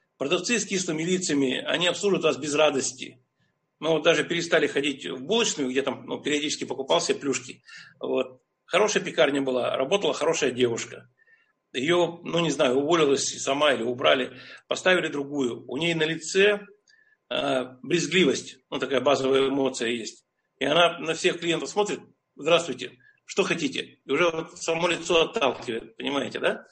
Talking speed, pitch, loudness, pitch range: 150 wpm, 160 Hz, -25 LUFS, 135-175 Hz